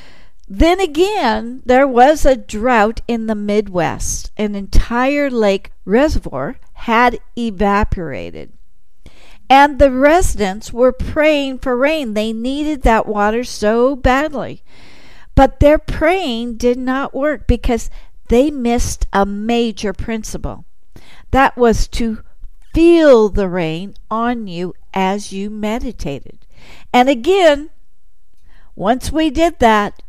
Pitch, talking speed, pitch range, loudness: 240 Hz, 115 wpm, 215-280 Hz, -15 LUFS